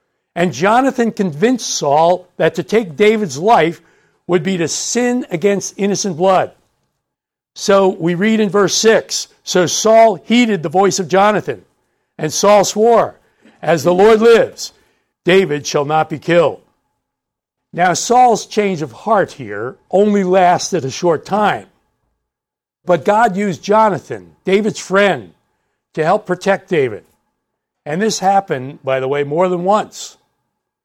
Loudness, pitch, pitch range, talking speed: -14 LUFS, 195 Hz, 175-215 Hz, 140 wpm